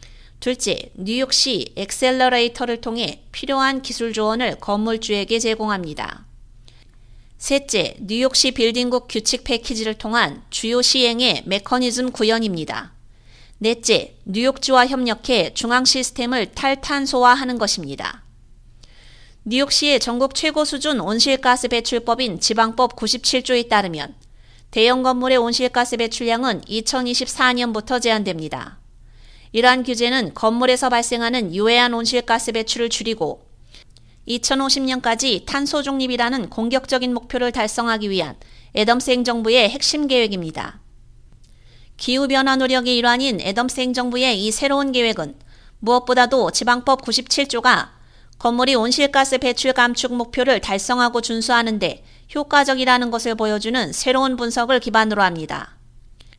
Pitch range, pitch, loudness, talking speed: 220-255 Hz, 240 Hz, -18 LUFS, 300 characters per minute